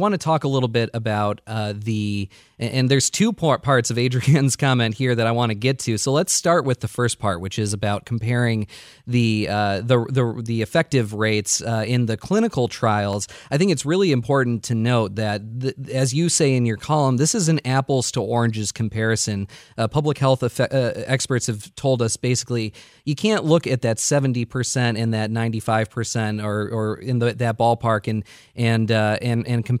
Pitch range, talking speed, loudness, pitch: 110-135 Hz, 200 wpm, -21 LUFS, 120 Hz